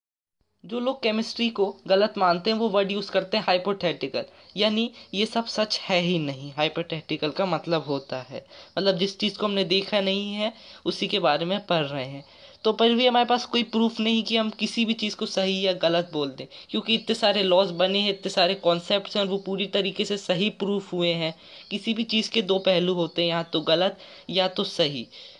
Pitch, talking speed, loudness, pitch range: 195 Hz, 215 wpm, -25 LUFS, 170-215 Hz